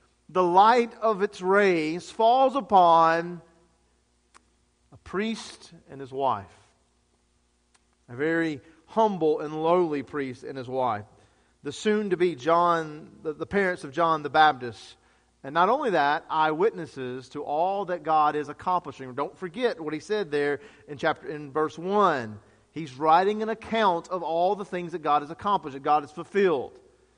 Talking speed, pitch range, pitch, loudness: 155 wpm, 135-185 Hz, 160 Hz, -25 LUFS